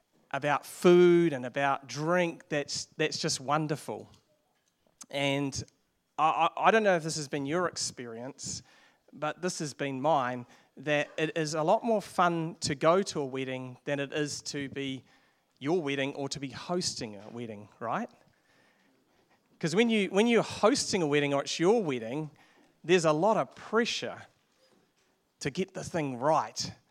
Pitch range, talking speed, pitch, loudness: 140-175 Hz, 165 wpm, 150 Hz, -29 LUFS